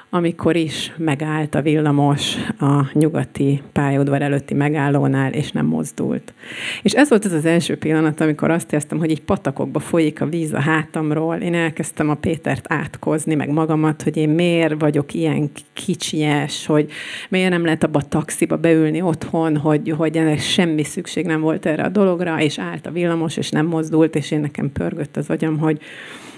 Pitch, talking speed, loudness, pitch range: 155 Hz, 175 wpm, -19 LUFS, 150-165 Hz